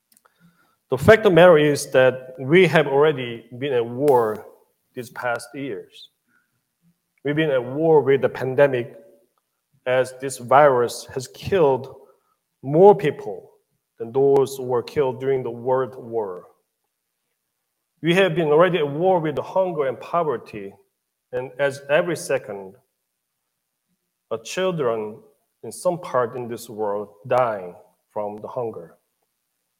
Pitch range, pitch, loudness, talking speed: 125-190 Hz, 145 Hz, -20 LUFS, 135 wpm